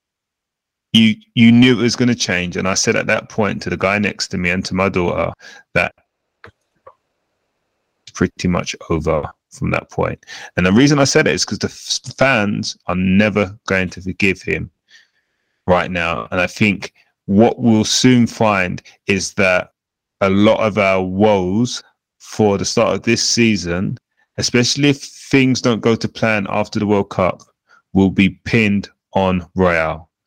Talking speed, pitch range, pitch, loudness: 170 wpm, 95-115 Hz, 100 Hz, -16 LUFS